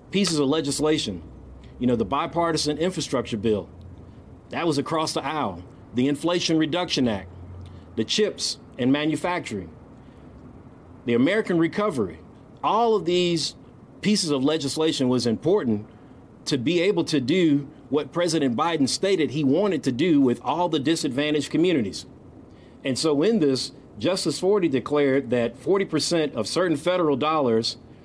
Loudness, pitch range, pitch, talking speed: -23 LUFS, 120-165 Hz, 145 Hz, 135 wpm